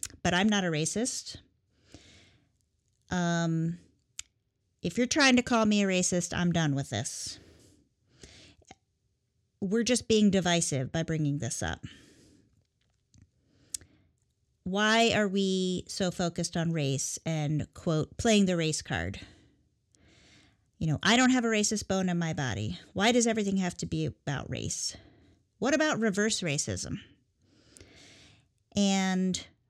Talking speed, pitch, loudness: 125 wpm, 155 Hz, -28 LUFS